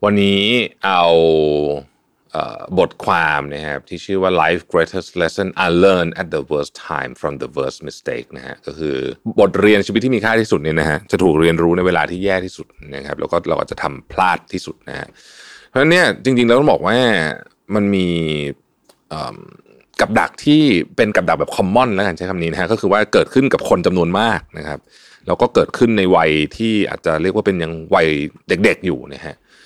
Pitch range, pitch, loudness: 80-100 Hz, 90 Hz, -16 LUFS